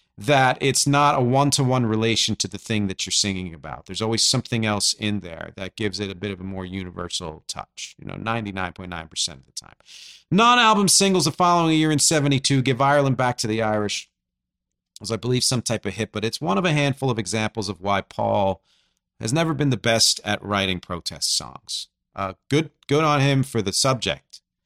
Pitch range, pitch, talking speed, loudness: 95-135 Hz, 110 Hz, 210 wpm, -21 LUFS